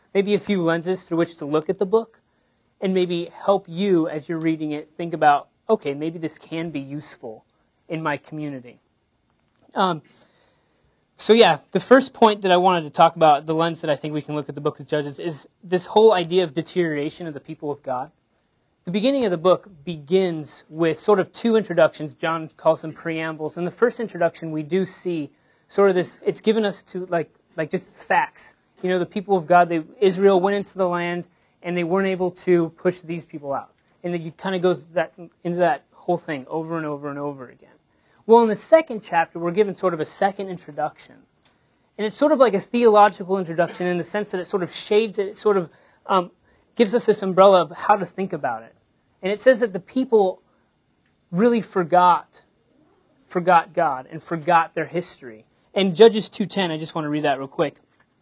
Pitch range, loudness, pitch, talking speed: 160-195 Hz, -21 LUFS, 175 Hz, 210 wpm